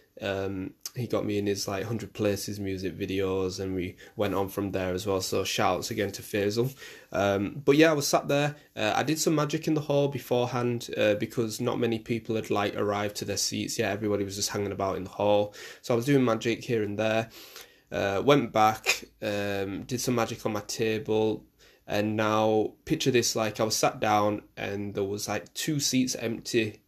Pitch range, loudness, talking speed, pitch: 100-120 Hz, -28 LUFS, 210 wpm, 110 Hz